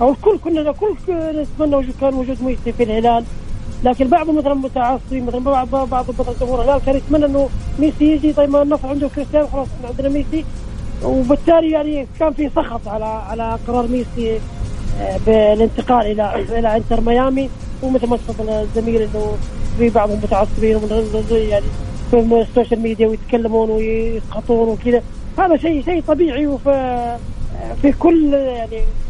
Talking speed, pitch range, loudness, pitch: 155 wpm, 225-285 Hz, -17 LUFS, 250 Hz